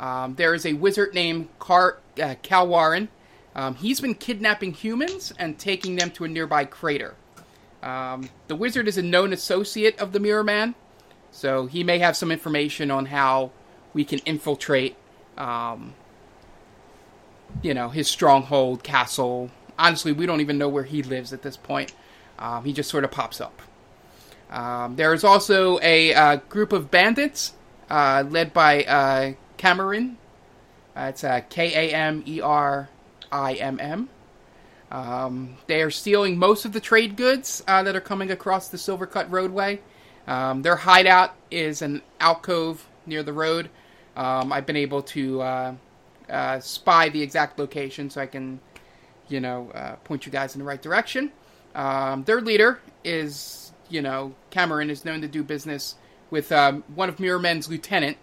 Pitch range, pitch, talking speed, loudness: 135-185 Hz, 155 Hz, 160 wpm, -22 LUFS